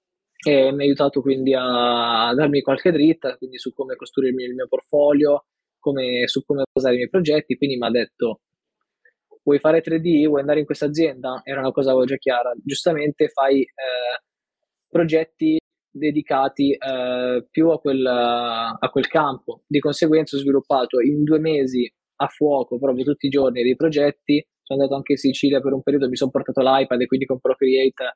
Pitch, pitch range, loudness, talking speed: 140 Hz, 130-150 Hz, -20 LUFS, 175 wpm